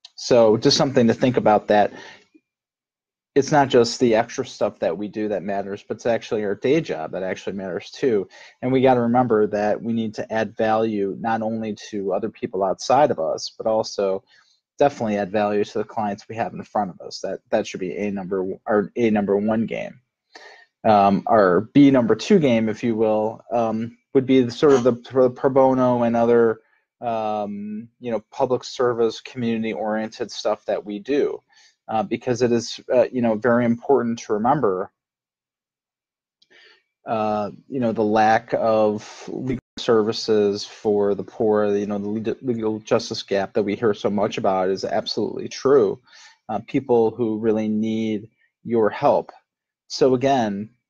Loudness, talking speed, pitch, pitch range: -21 LUFS, 175 wpm, 110 Hz, 105-125 Hz